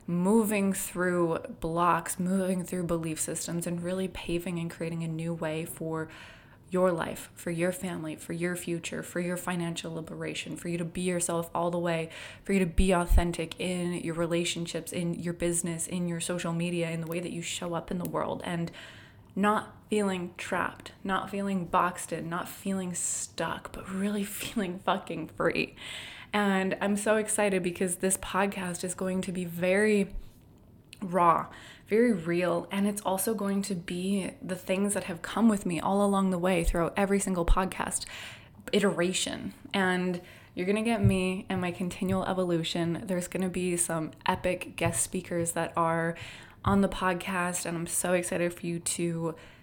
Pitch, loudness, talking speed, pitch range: 180 Hz, -30 LUFS, 175 wpm, 170-190 Hz